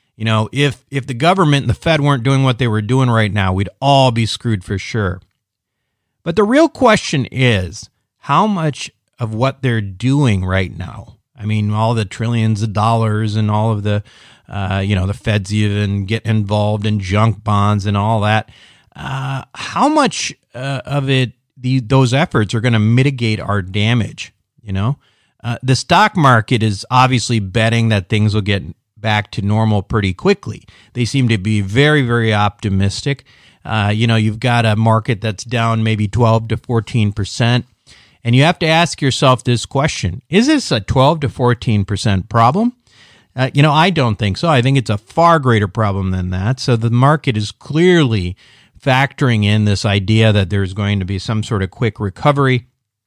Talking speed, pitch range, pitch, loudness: 185 wpm, 105-135 Hz, 115 Hz, -15 LUFS